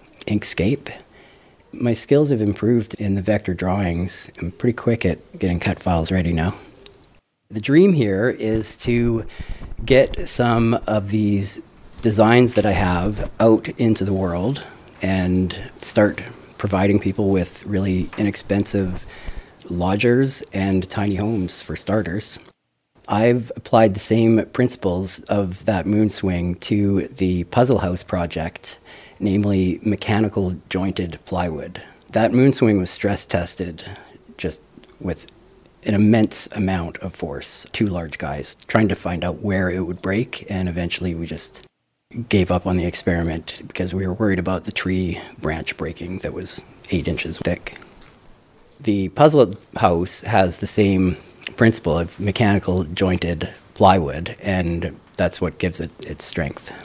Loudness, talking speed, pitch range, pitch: -20 LUFS, 140 wpm, 90-110 Hz, 100 Hz